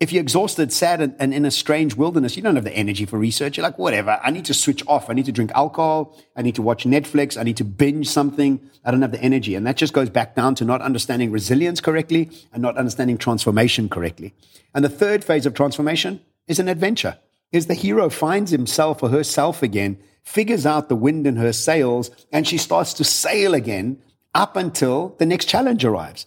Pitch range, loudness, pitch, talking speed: 120-160 Hz, -19 LUFS, 140 Hz, 220 wpm